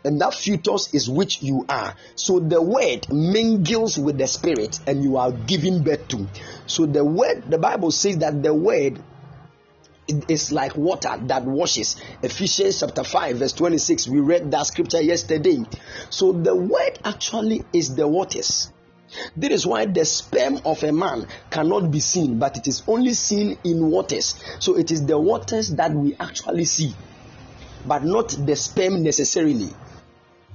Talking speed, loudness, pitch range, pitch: 165 wpm, -21 LUFS, 140-175 Hz, 155 Hz